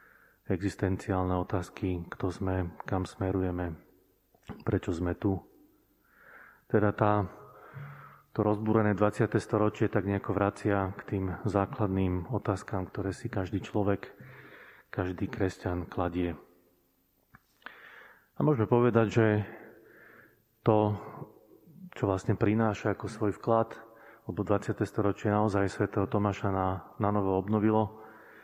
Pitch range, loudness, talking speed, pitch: 95-110 Hz, -30 LUFS, 105 wpm, 100 Hz